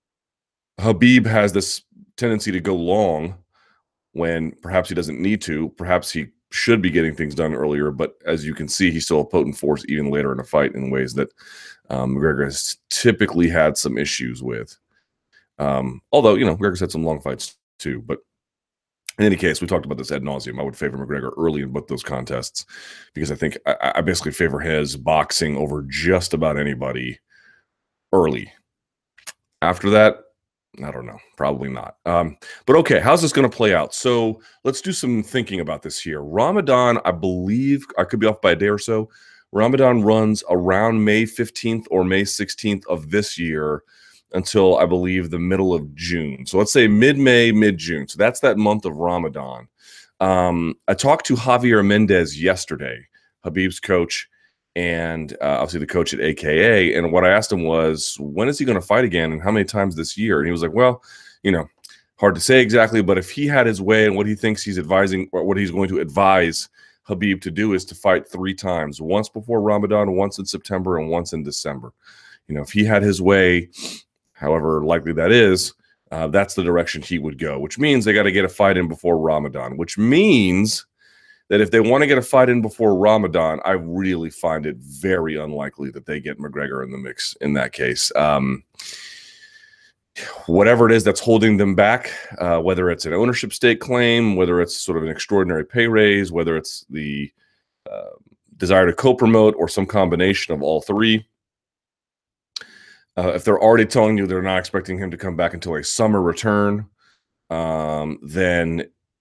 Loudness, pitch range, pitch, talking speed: -19 LUFS, 80-110 Hz, 95 Hz, 195 wpm